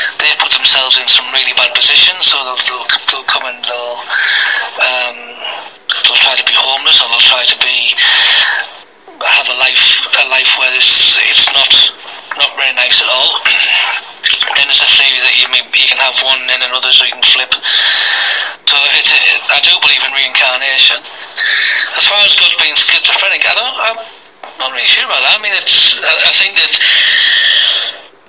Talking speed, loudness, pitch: 180 wpm, -6 LUFS, 225 Hz